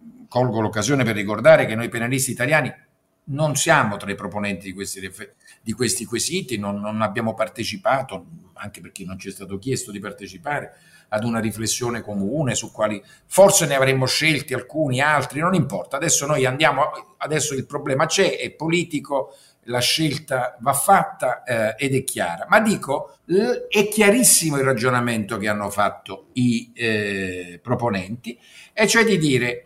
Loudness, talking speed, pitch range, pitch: -20 LUFS, 160 wpm, 110-150 Hz, 125 Hz